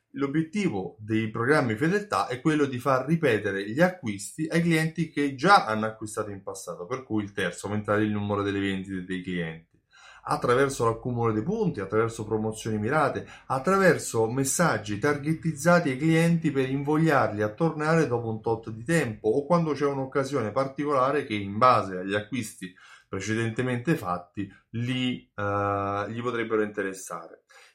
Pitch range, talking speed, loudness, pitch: 105-150 Hz, 145 wpm, -26 LUFS, 120 Hz